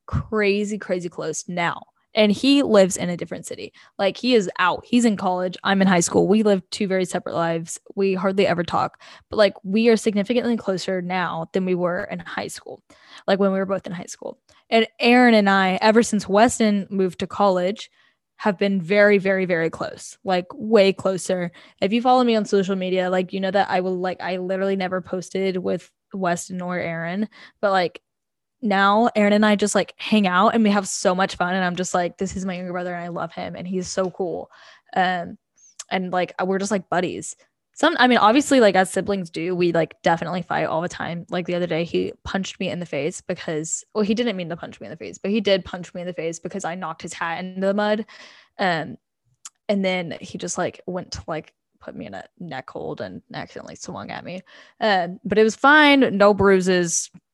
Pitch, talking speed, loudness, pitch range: 190 Hz, 225 wpm, -21 LUFS, 180-210 Hz